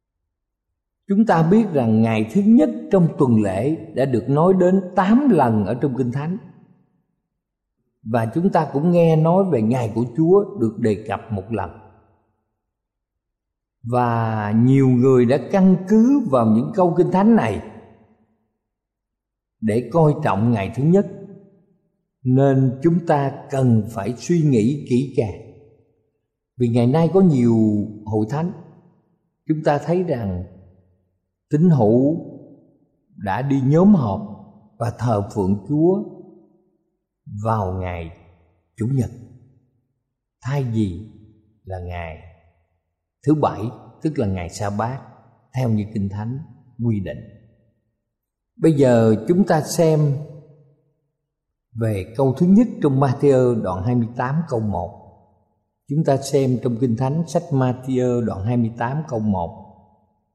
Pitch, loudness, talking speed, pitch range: 120 Hz, -19 LUFS, 130 wpm, 110-155 Hz